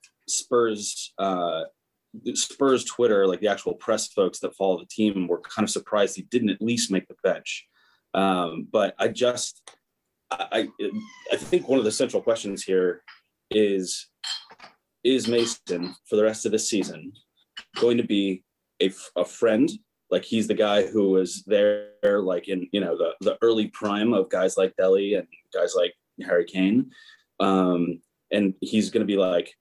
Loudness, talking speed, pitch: -24 LUFS, 170 wpm, 115 Hz